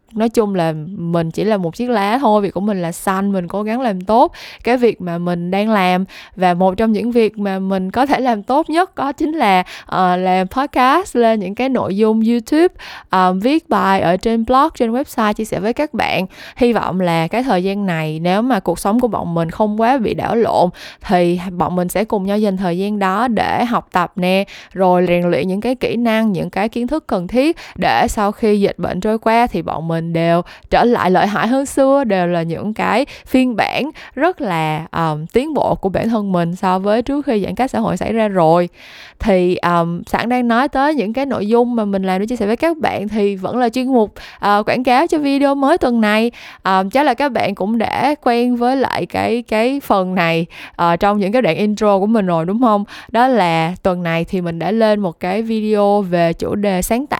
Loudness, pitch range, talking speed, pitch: -16 LUFS, 185-240 Hz, 240 wpm, 210 Hz